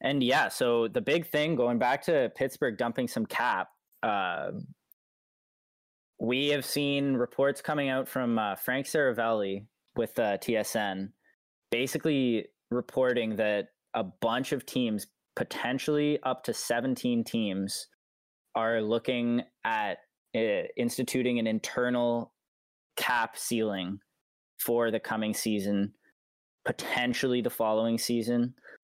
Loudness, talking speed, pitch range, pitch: -30 LUFS, 115 wpm, 110-130 Hz, 120 Hz